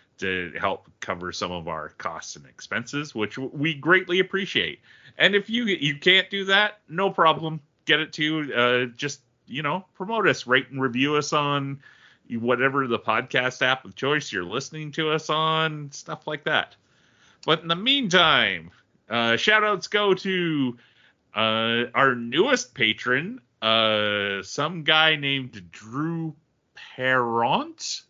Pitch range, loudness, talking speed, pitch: 115-160 Hz, -23 LUFS, 145 wpm, 140 Hz